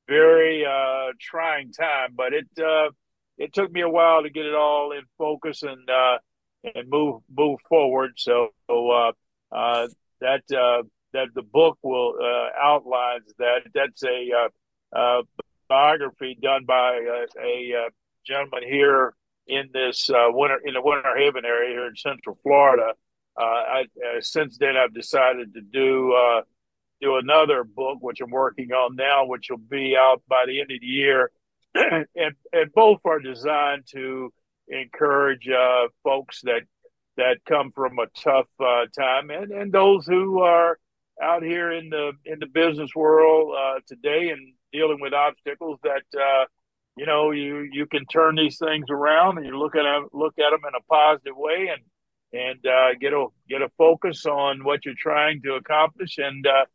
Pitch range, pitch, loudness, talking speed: 130-155 Hz, 140 Hz, -22 LUFS, 170 wpm